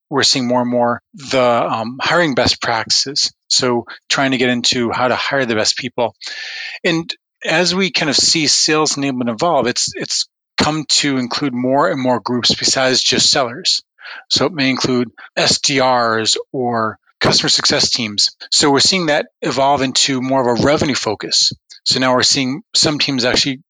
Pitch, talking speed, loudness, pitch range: 130 Hz, 175 wpm, -15 LUFS, 125-150 Hz